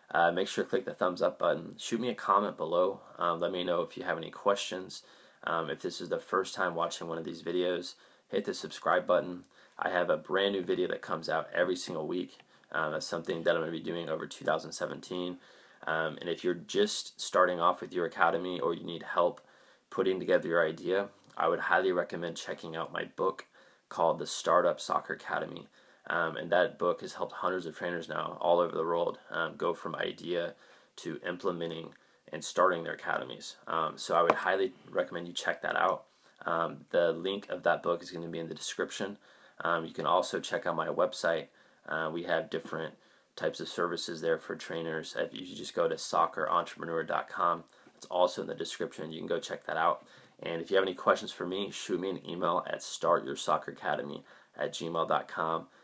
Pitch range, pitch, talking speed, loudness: 85-95 Hz, 85 Hz, 205 wpm, -32 LUFS